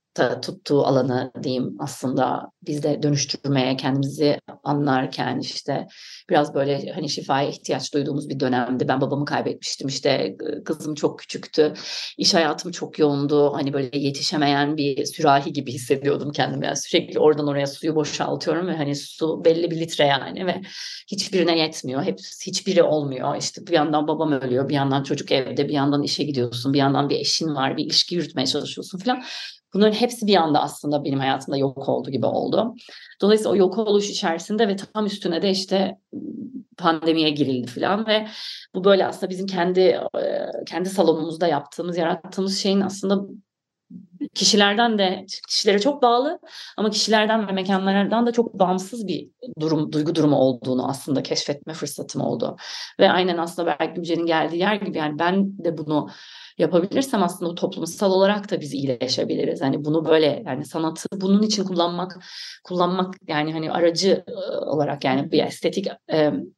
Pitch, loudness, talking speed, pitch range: 165 Hz, -22 LUFS, 155 wpm, 145-195 Hz